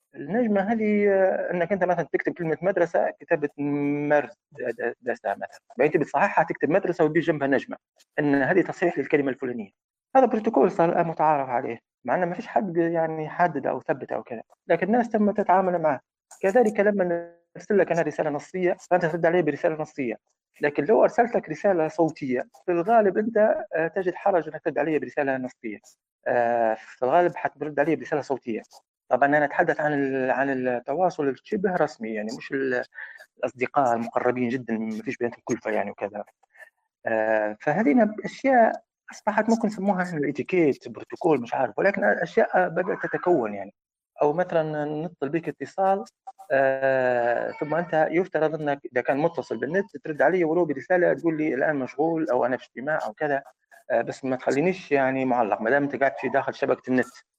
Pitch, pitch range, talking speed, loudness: 155 Hz, 135-180 Hz, 160 wpm, -24 LUFS